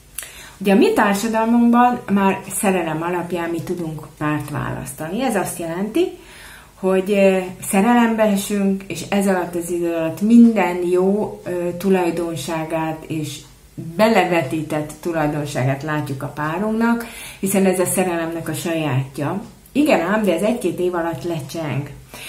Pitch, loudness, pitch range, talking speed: 175 Hz, -19 LUFS, 160-200 Hz, 125 wpm